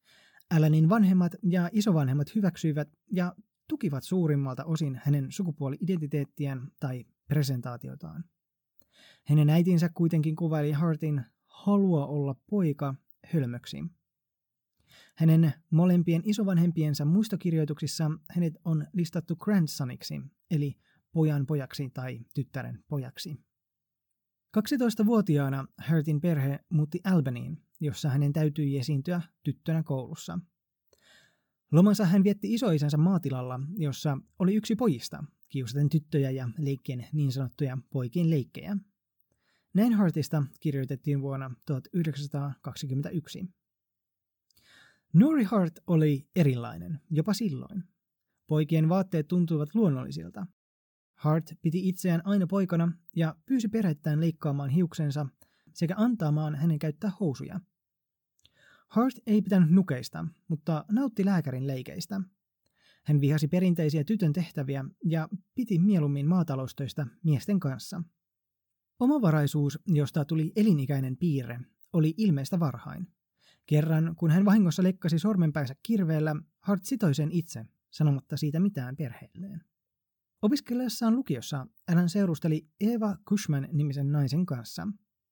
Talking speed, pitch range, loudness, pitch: 100 wpm, 145-185 Hz, -28 LUFS, 160 Hz